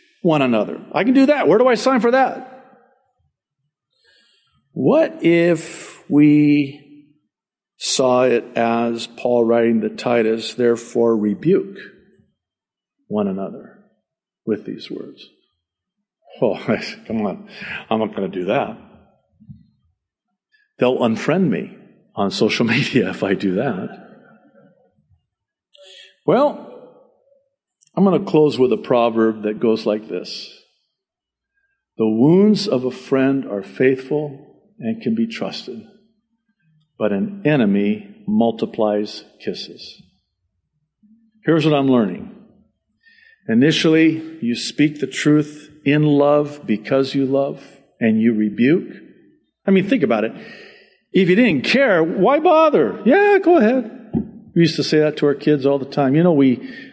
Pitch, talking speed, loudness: 155 Hz, 130 wpm, -17 LUFS